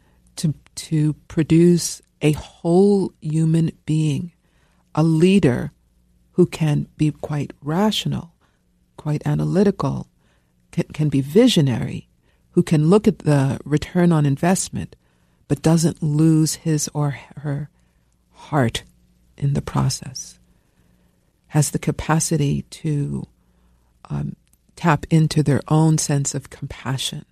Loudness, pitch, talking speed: -20 LUFS, 150 Hz, 110 wpm